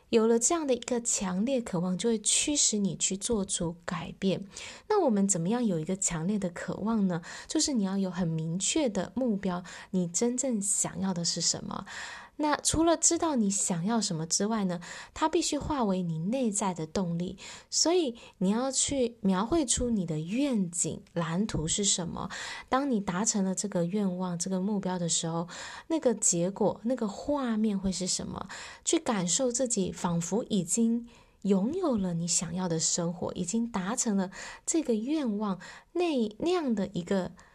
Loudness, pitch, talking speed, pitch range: -29 LUFS, 200 Hz, 255 characters per minute, 180-245 Hz